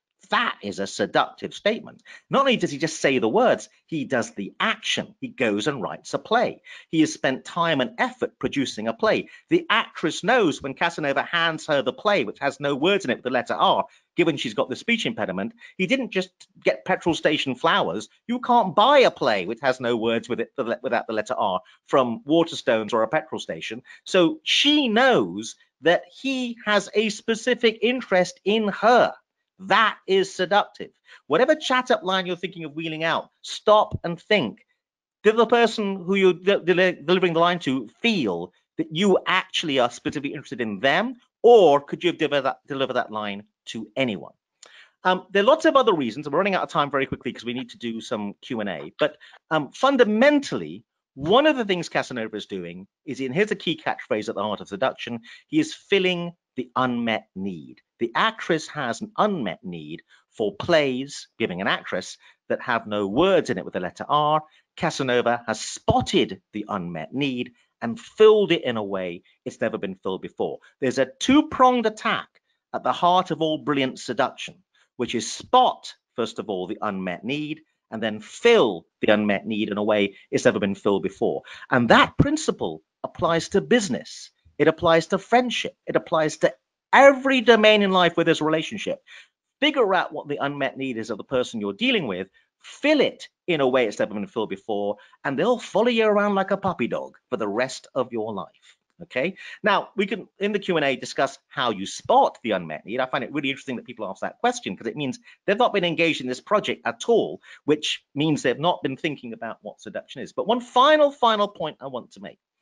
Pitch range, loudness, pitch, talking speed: 130-215 Hz, -23 LUFS, 170 Hz, 200 wpm